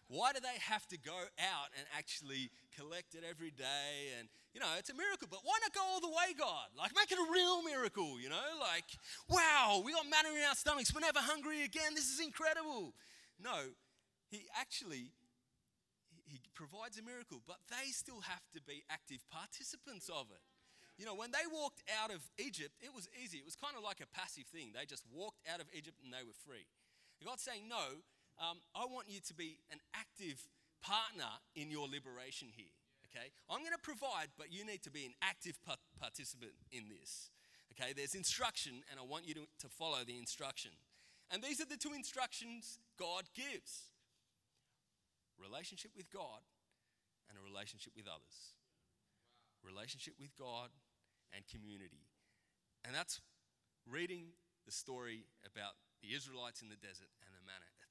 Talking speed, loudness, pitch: 180 wpm, -42 LUFS, 170 Hz